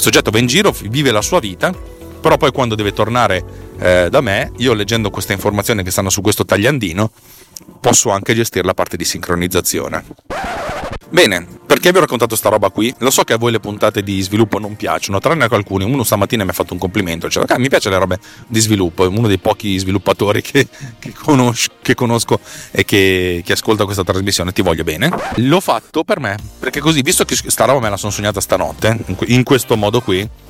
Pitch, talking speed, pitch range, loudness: 105 Hz, 215 wpm, 95-115 Hz, -14 LUFS